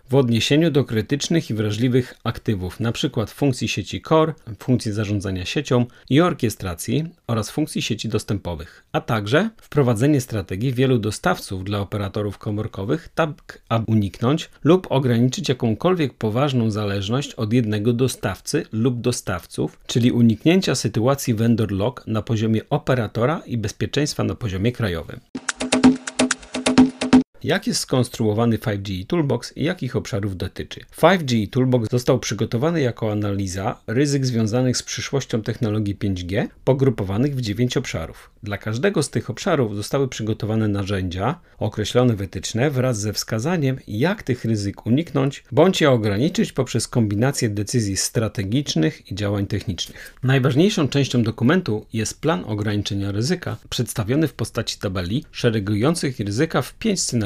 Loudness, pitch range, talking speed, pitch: -21 LUFS, 105-140 Hz, 130 wpm, 120 Hz